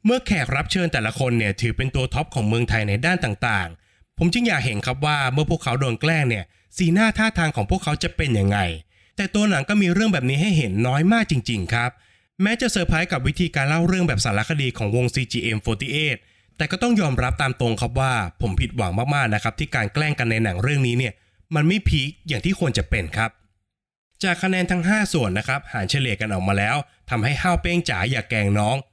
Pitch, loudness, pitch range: 130 Hz, -21 LUFS, 110-165 Hz